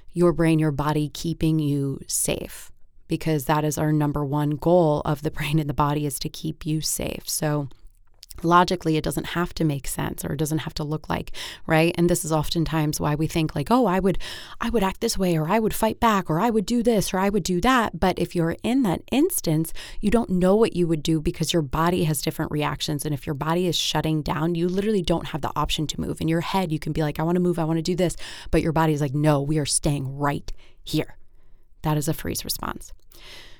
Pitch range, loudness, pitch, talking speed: 150-175 Hz, -23 LUFS, 160 Hz, 245 wpm